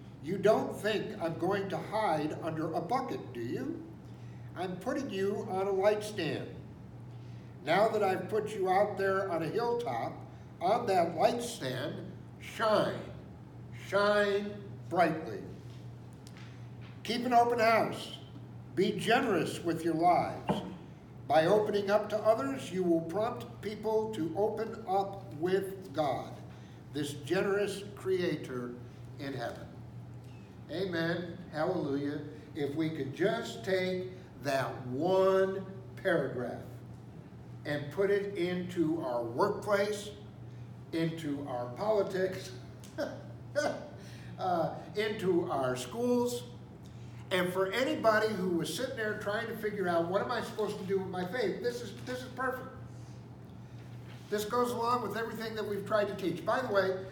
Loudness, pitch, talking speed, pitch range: -33 LUFS, 185 Hz, 130 wpm, 140-210 Hz